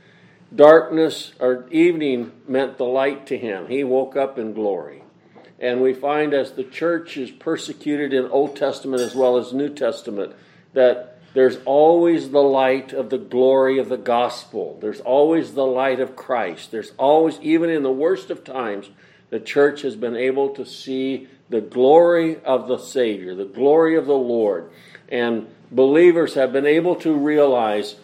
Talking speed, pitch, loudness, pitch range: 165 wpm, 135 Hz, -19 LUFS, 125-150 Hz